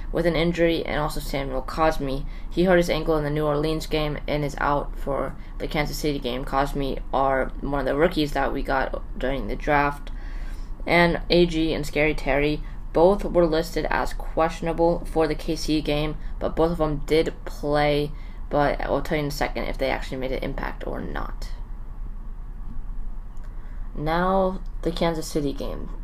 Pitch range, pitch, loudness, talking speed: 135-160 Hz, 150 Hz, -24 LUFS, 175 wpm